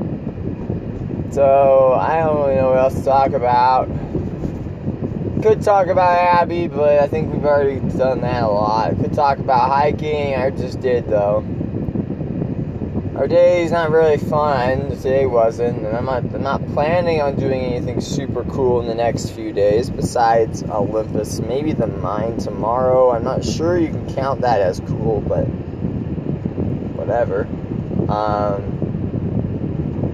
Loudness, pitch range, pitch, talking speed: -18 LUFS, 115-150 Hz, 130 Hz, 145 wpm